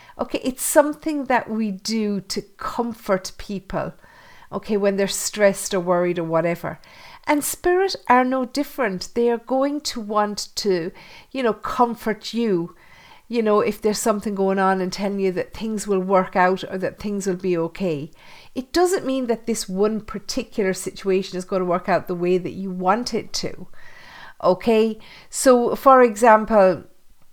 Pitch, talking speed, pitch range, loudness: 210 Hz, 170 wpm, 190-245 Hz, -21 LUFS